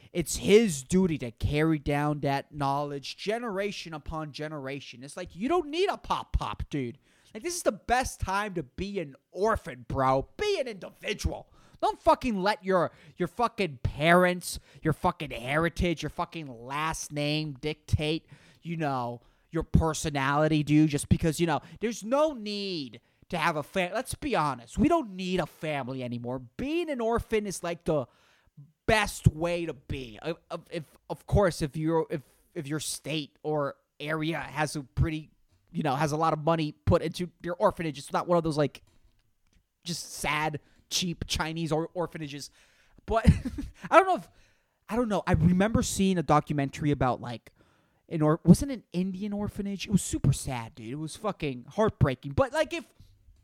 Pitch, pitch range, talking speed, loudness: 160 Hz, 140-185 Hz, 175 wpm, -29 LUFS